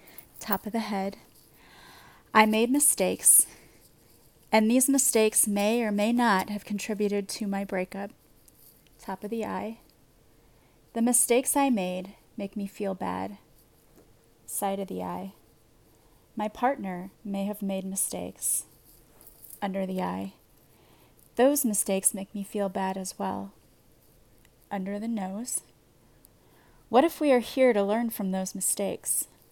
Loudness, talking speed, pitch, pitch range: -26 LUFS, 130 wpm, 195 Hz, 155-220 Hz